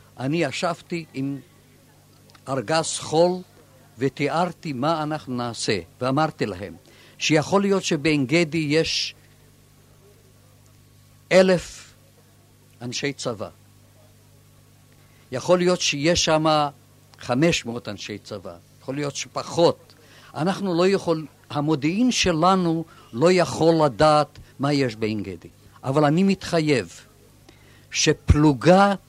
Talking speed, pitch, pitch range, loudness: 95 wpm, 140 Hz, 115-160 Hz, -22 LUFS